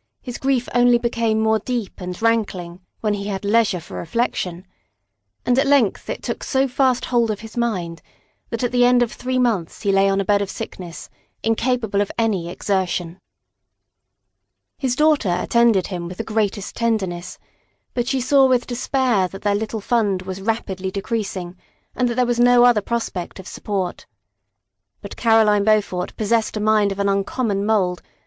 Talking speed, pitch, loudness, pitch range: 175 wpm, 210 Hz, -21 LUFS, 180-240 Hz